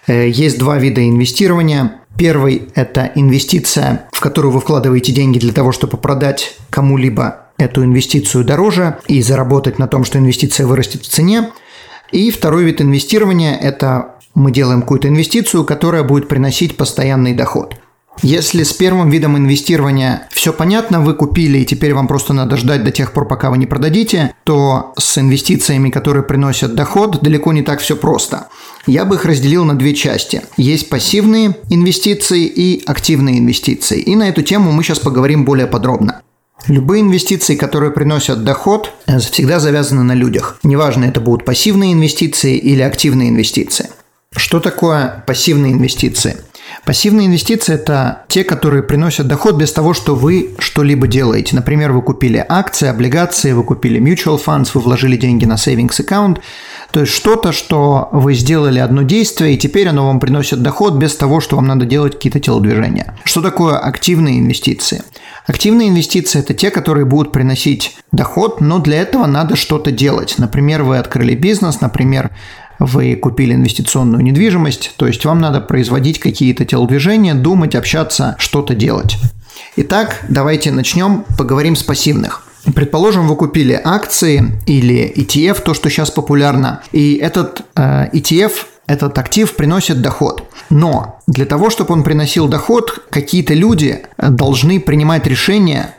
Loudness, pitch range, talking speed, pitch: -12 LUFS, 135-165 Hz, 150 wpm, 145 Hz